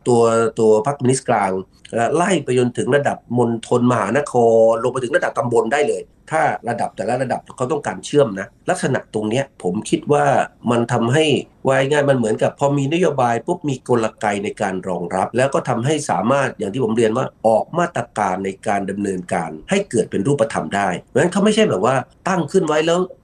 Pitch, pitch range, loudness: 120 Hz, 110-145 Hz, -18 LUFS